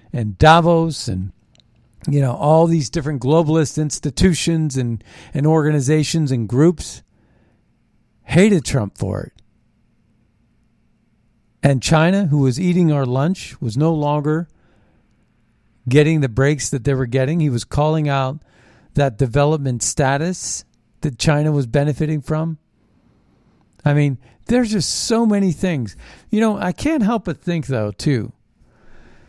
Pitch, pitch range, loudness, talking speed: 140 Hz, 115-160 Hz, -18 LUFS, 130 wpm